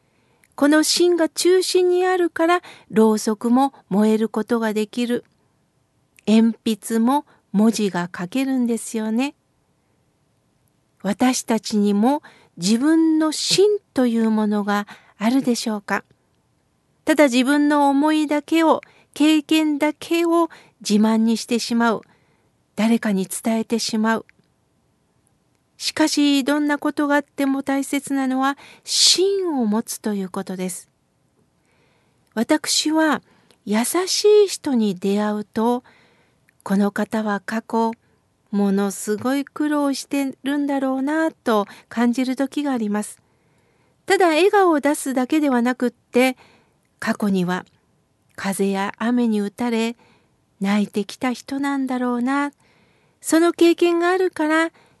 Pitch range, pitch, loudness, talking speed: 215-295 Hz, 245 Hz, -20 LUFS, 230 characters per minute